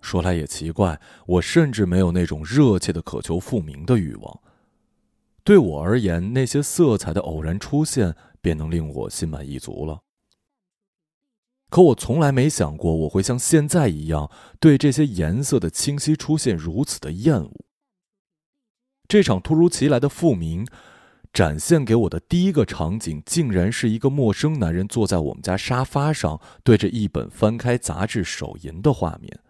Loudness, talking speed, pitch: -20 LUFS, 250 characters per minute, 115 Hz